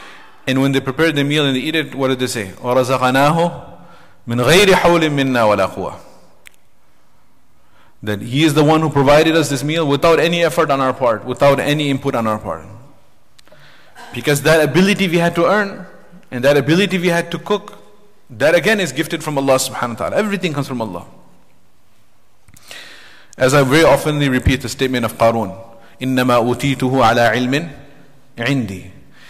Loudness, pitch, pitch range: -15 LUFS, 140 Hz, 120-160 Hz